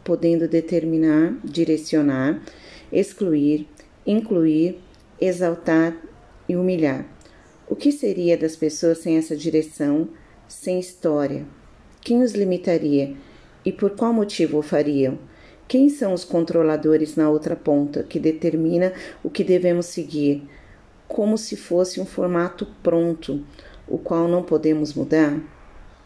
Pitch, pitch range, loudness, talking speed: 165 Hz, 155-180 Hz, -21 LUFS, 115 wpm